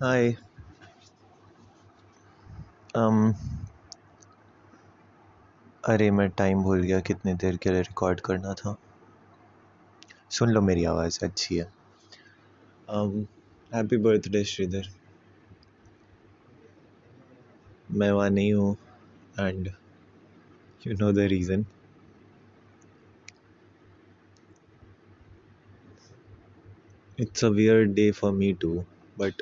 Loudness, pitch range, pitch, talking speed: -26 LUFS, 95-110 Hz, 105 Hz, 80 wpm